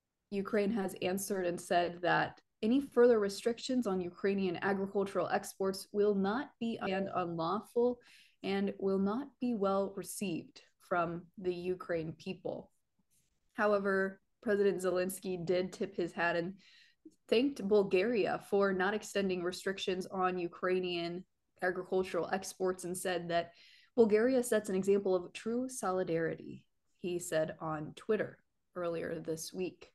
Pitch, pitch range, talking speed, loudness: 190 Hz, 180-205 Hz, 125 wpm, -34 LUFS